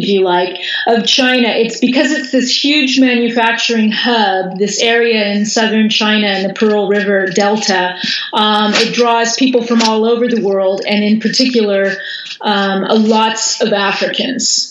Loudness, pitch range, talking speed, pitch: -12 LUFS, 205-235 Hz, 155 wpm, 220 Hz